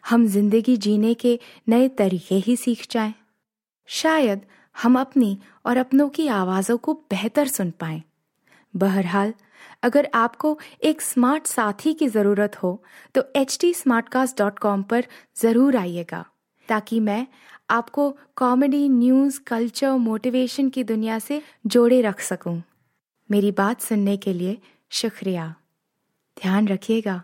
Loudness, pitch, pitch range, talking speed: -21 LUFS, 230 Hz, 205-260 Hz, 120 wpm